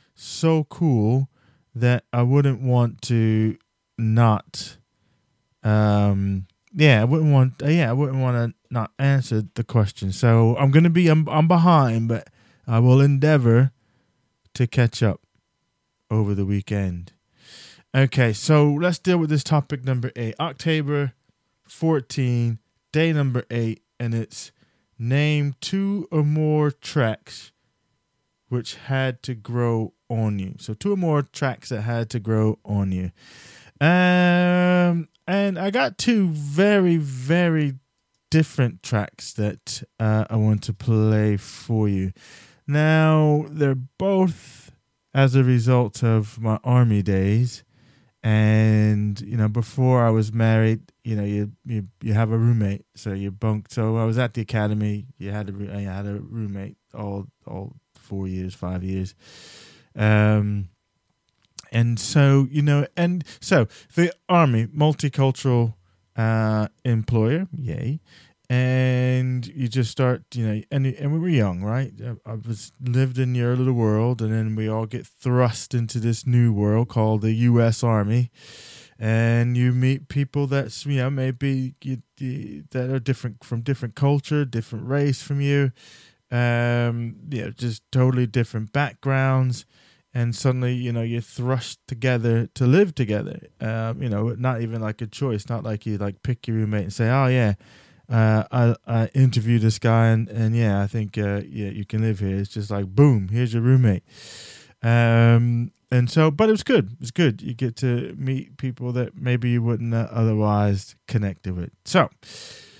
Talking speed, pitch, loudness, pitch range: 155 wpm, 120 Hz, -22 LUFS, 110-135 Hz